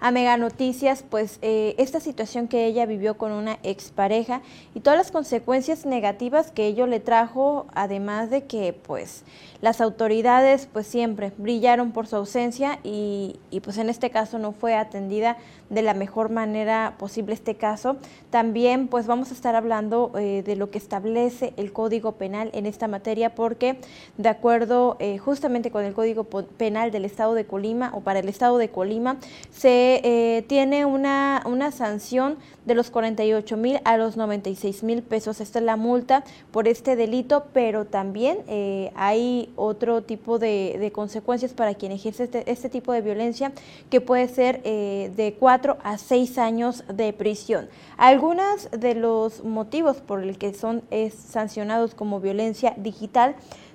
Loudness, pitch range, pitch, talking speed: -23 LUFS, 215-250 Hz, 230 Hz, 165 wpm